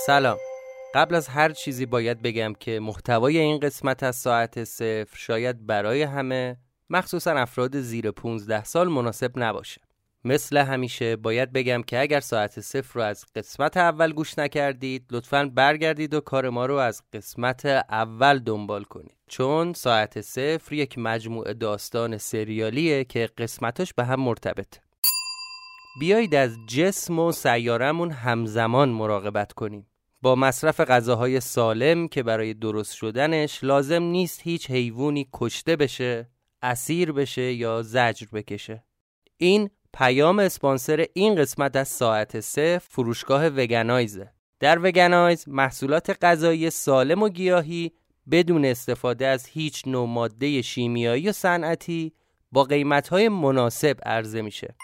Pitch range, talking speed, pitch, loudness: 115-155 Hz, 130 wpm, 130 Hz, -23 LUFS